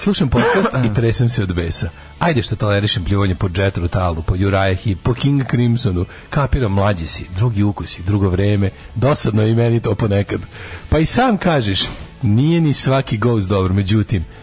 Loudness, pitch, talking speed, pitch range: -17 LUFS, 105 Hz, 175 wpm, 95-120 Hz